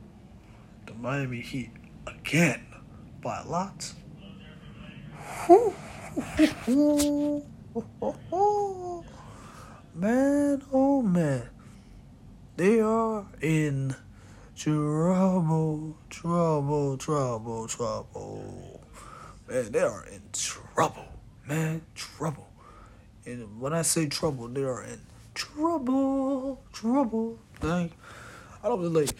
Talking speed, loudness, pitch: 80 wpm, -28 LUFS, 155 Hz